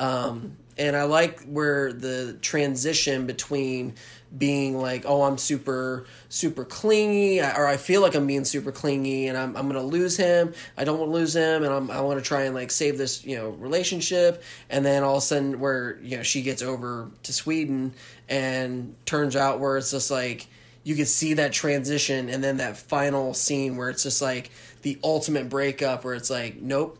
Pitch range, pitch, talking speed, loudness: 130-145 Hz, 135 Hz, 200 wpm, -25 LUFS